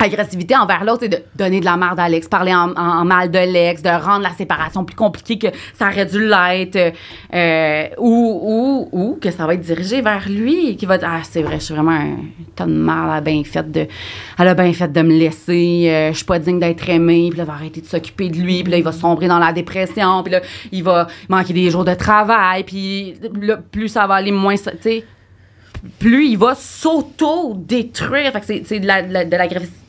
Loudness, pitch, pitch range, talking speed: -16 LUFS, 180 Hz, 170-205 Hz, 235 wpm